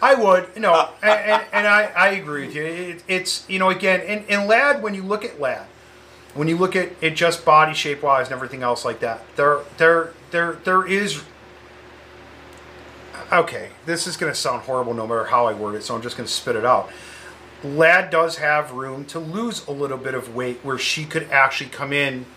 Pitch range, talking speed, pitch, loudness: 130-185 Hz, 215 wpm, 155 Hz, -20 LUFS